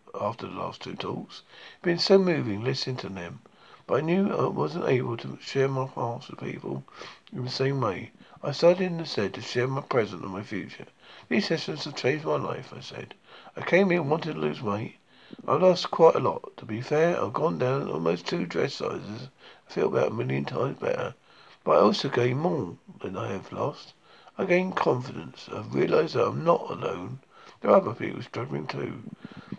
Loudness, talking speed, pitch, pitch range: -27 LUFS, 205 wpm, 145 Hz, 125-180 Hz